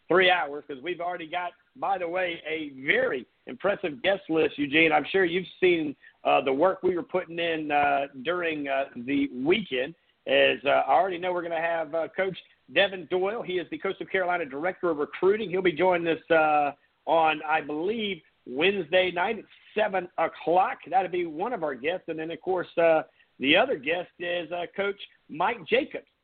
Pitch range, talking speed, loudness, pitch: 160-190 Hz, 190 wpm, -26 LUFS, 180 Hz